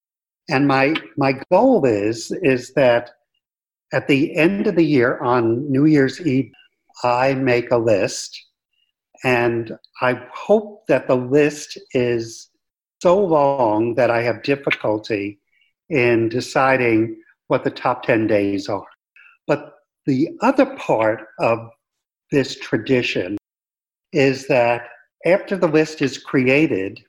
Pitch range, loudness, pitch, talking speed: 115-150 Hz, -19 LUFS, 130 Hz, 125 wpm